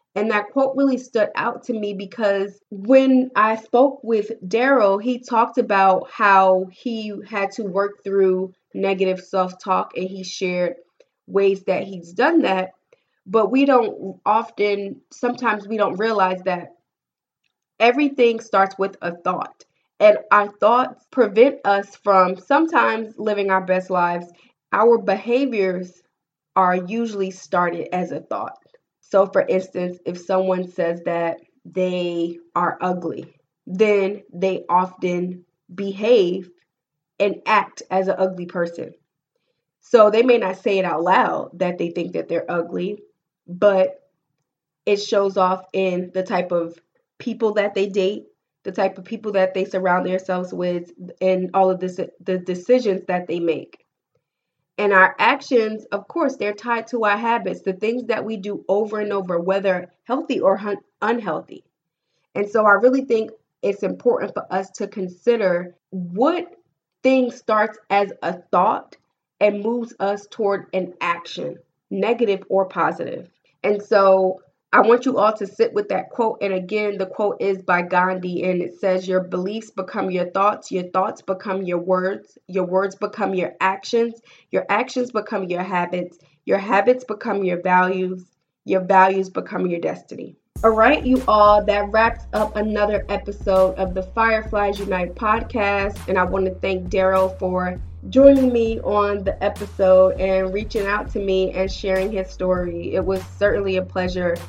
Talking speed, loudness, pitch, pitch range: 155 wpm, -20 LUFS, 195 Hz, 185-215 Hz